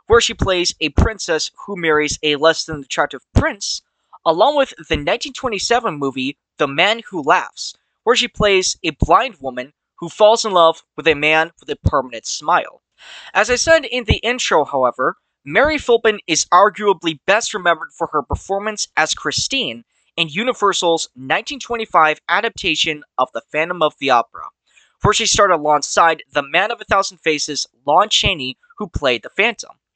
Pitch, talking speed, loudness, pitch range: 180 Hz, 165 wpm, -17 LUFS, 155-225 Hz